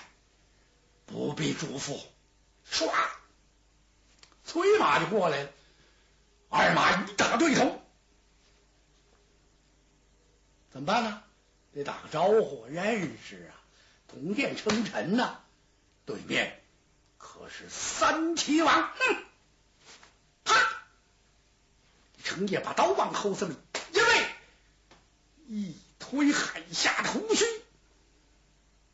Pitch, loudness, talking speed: 320 Hz, -28 LUFS, 125 characters per minute